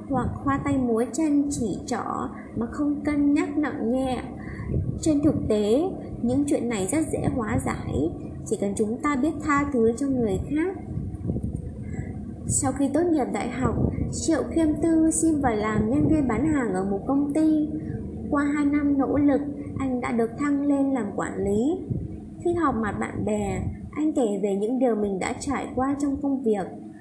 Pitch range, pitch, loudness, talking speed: 235-295 Hz, 275 Hz, -25 LUFS, 185 wpm